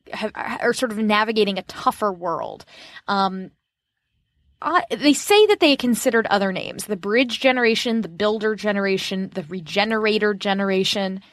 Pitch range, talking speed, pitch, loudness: 195-235 Hz, 140 wpm, 210 Hz, -20 LUFS